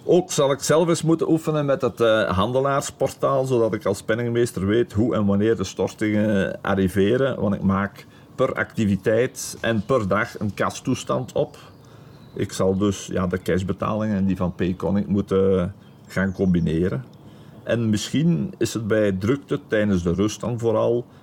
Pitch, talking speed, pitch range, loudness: 110 Hz, 160 wpm, 100-125 Hz, -22 LUFS